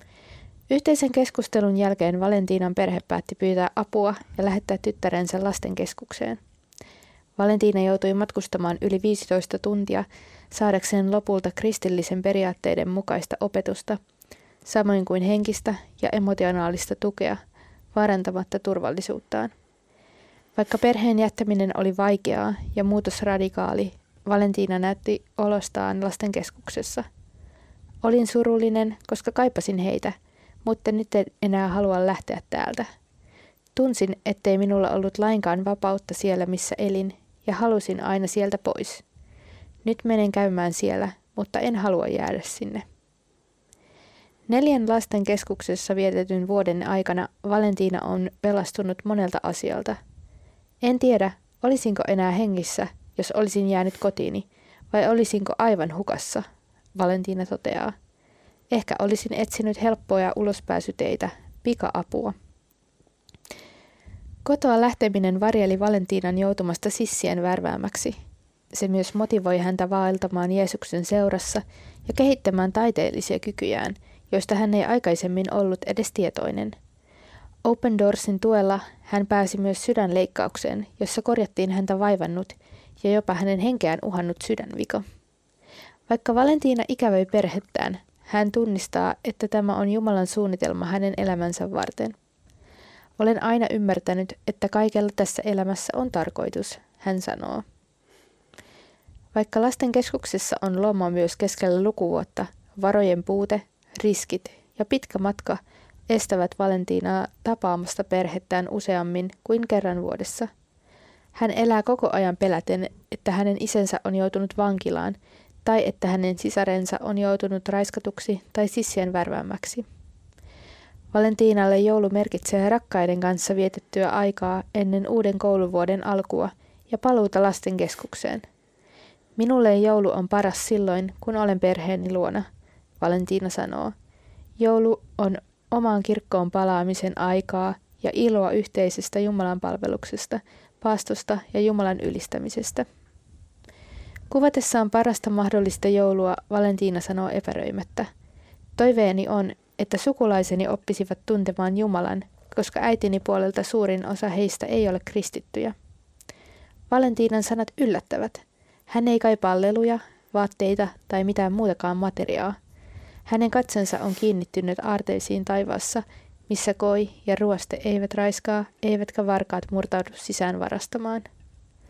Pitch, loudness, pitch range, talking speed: 200 Hz, -24 LUFS, 185-215 Hz, 110 wpm